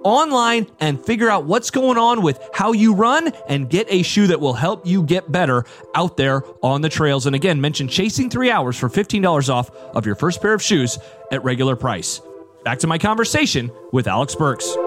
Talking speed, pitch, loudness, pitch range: 205 wpm, 155 Hz, -18 LUFS, 130-200 Hz